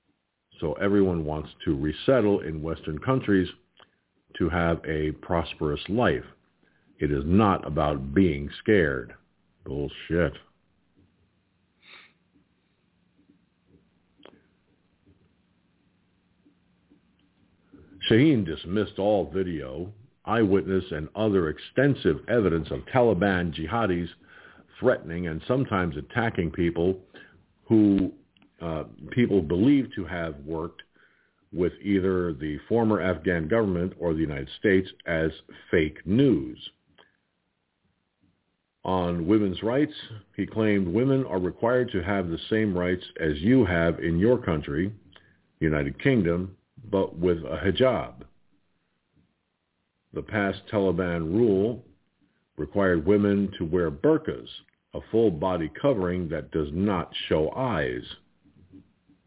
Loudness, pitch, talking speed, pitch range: -26 LUFS, 95 Hz, 100 wpm, 80-105 Hz